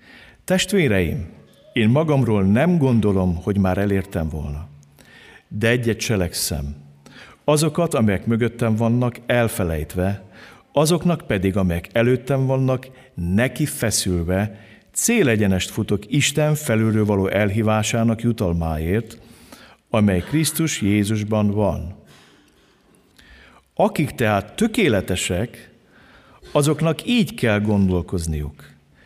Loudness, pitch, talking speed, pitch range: -20 LUFS, 110 Hz, 85 wpm, 95-130 Hz